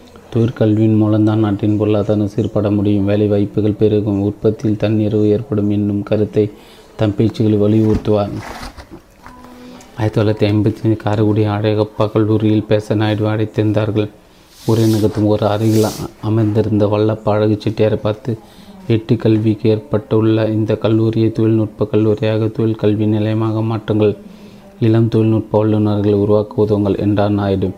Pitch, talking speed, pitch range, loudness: 105 Hz, 110 wpm, 105-110 Hz, -15 LUFS